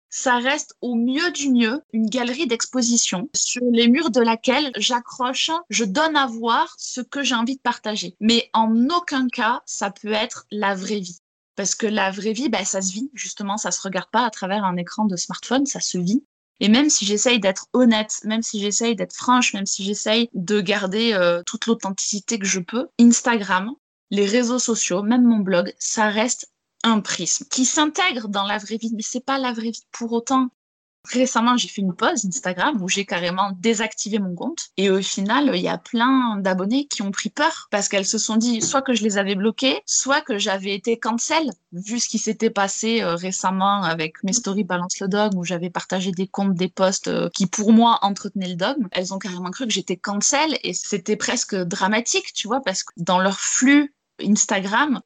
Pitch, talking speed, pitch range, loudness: 220 Hz, 205 wpm, 195-245 Hz, -21 LUFS